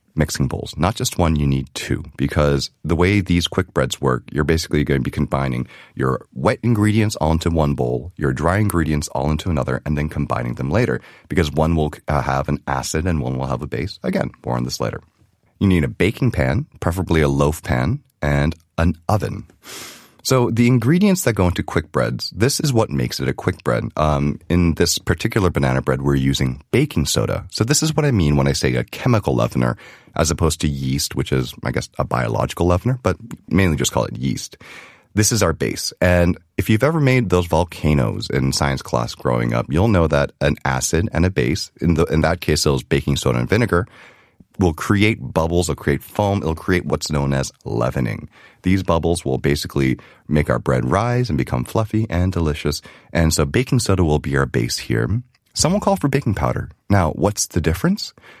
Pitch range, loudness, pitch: 70-100 Hz, -19 LUFS, 80 Hz